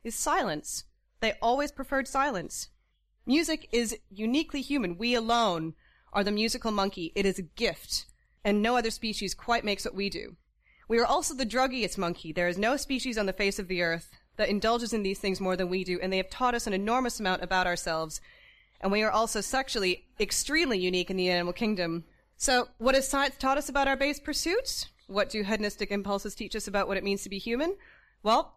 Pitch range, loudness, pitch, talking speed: 195-255 Hz, -29 LUFS, 215 Hz, 210 wpm